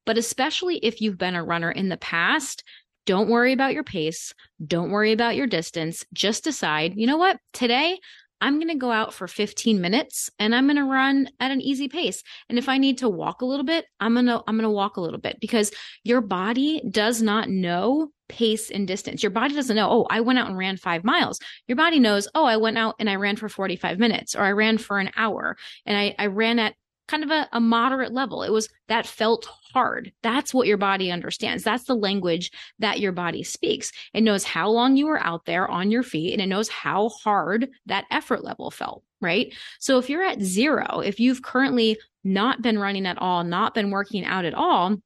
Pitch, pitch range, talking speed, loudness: 220 Hz, 200-255 Hz, 220 wpm, -23 LUFS